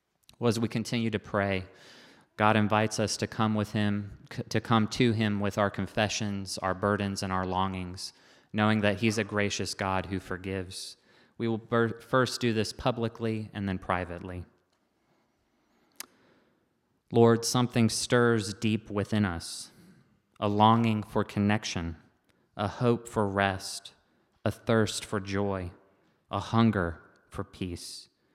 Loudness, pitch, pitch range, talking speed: -29 LUFS, 105 Hz, 95-115 Hz, 135 wpm